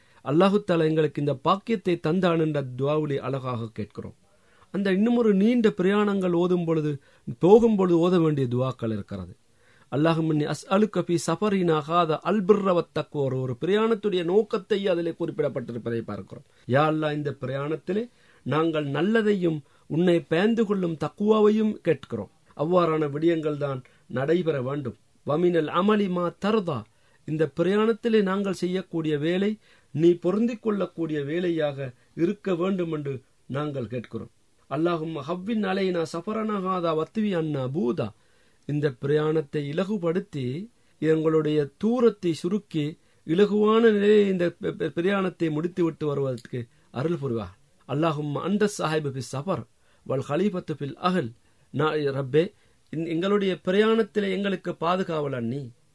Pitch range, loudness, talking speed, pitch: 140-190 Hz, -25 LUFS, 100 wpm, 160 Hz